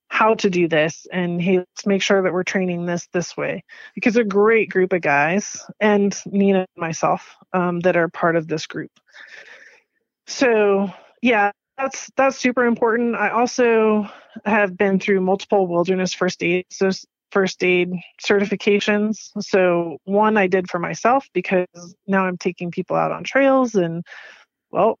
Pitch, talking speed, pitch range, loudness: 195 Hz, 160 wpm, 180-210 Hz, -19 LUFS